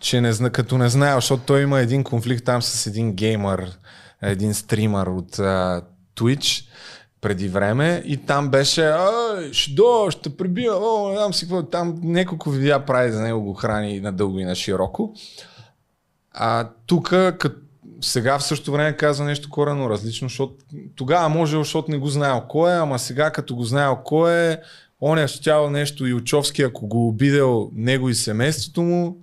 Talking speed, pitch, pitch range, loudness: 175 wpm, 135 Hz, 115-155 Hz, -20 LUFS